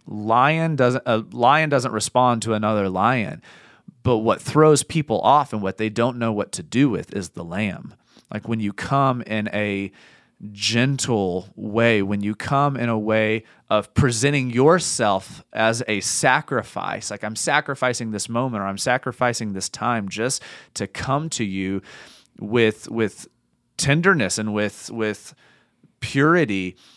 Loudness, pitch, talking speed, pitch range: -21 LUFS, 115 Hz, 150 wpm, 105-130 Hz